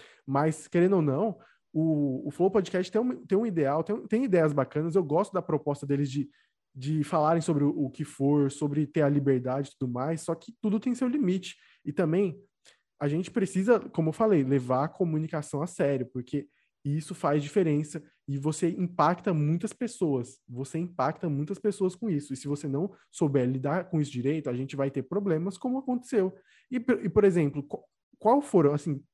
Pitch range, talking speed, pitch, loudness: 145-190 Hz, 195 wpm, 160 Hz, -28 LUFS